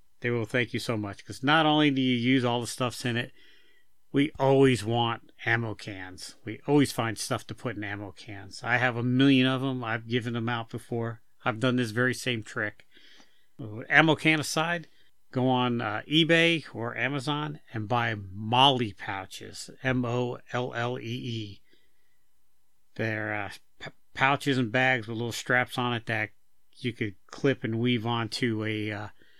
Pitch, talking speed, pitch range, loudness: 120 Hz, 180 wpm, 110-130 Hz, -27 LUFS